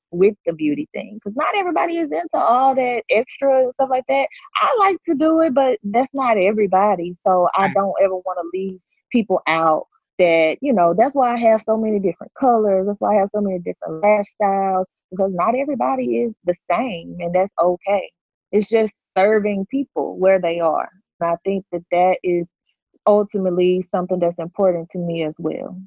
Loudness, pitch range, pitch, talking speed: -19 LUFS, 180-230 Hz, 195 Hz, 195 wpm